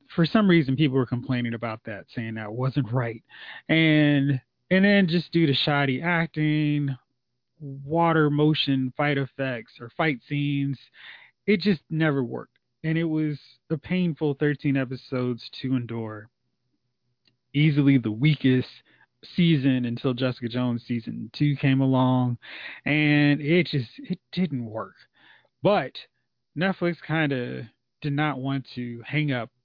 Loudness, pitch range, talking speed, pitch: -24 LUFS, 125-155 Hz, 135 wpm, 140 Hz